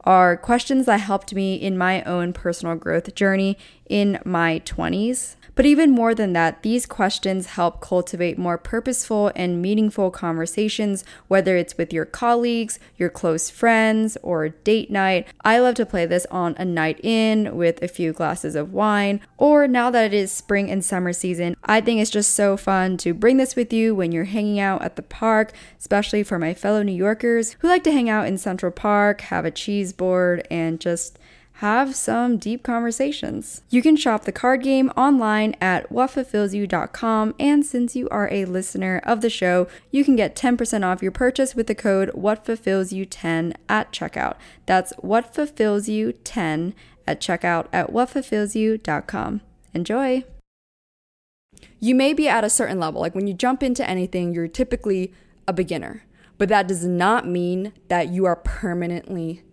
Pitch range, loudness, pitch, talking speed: 180-230 Hz, -21 LUFS, 200 Hz, 170 wpm